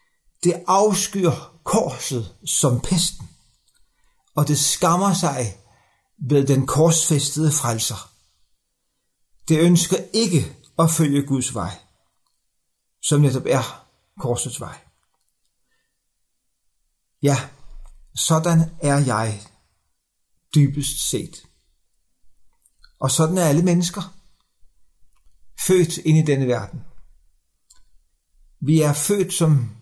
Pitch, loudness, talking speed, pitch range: 145 Hz, -20 LUFS, 90 wpm, 120-170 Hz